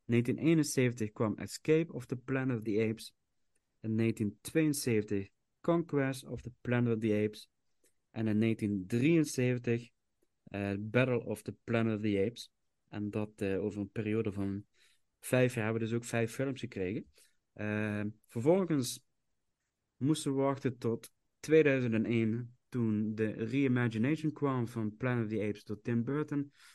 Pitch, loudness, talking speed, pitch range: 115 Hz, -33 LUFS, 145 wpm, 105-130 Hz